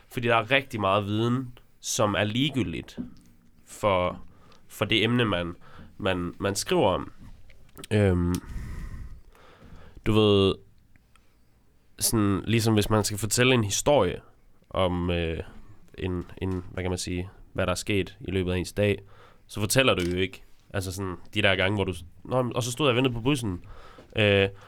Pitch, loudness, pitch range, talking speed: 100 Hz, -26 LUFS, 90-110 Hz, 165 wpm